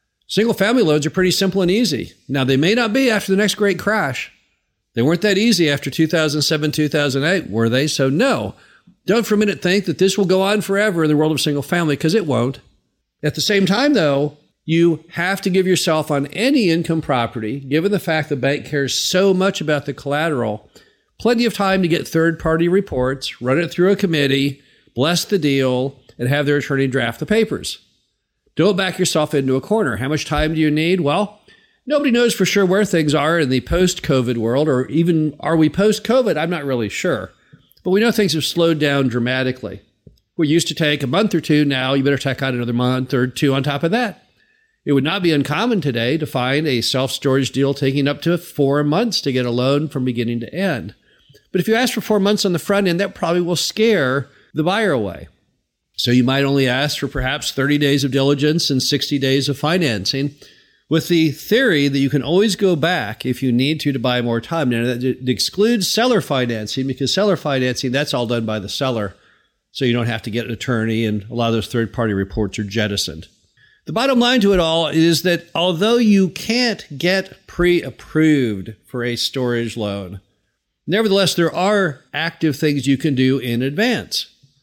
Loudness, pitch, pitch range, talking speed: -18 LUFS, 150 Hz, 130-185 Hz, 210 wpm